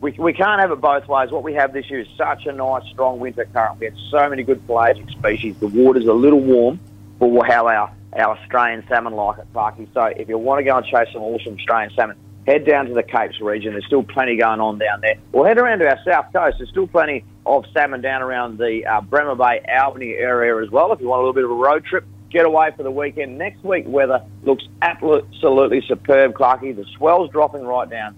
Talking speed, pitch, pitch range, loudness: 245 wpm, 125 Hz, 110-140 Hz, -18 LUFS